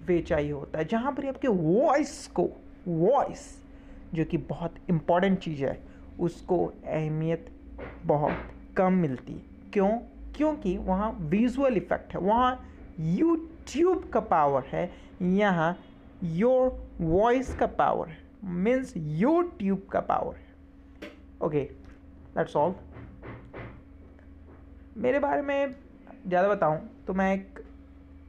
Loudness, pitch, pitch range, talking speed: -28 LUFS, 180 Hz, 155-245 Hz, 115 wpm